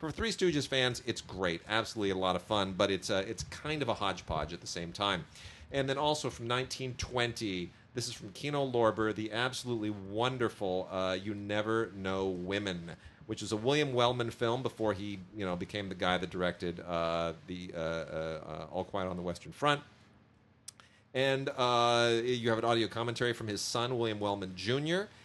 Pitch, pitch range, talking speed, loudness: 110 Hz, 95-120 Hz, 190 wpm, -34 LUFS